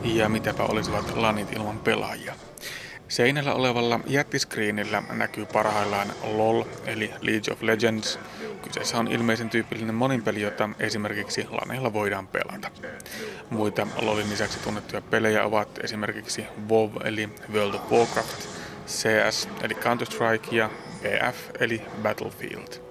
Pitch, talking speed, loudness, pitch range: 110 Hz, 120 wpm, -26 LUFS, 105-115 Hz